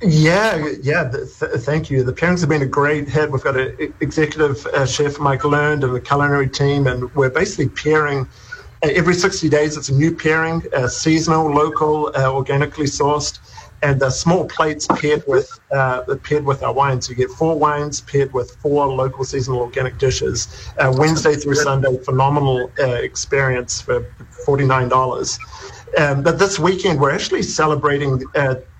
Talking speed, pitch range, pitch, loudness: 175 wpm, 130-155 Hz, 145 Hz, -17 LUFS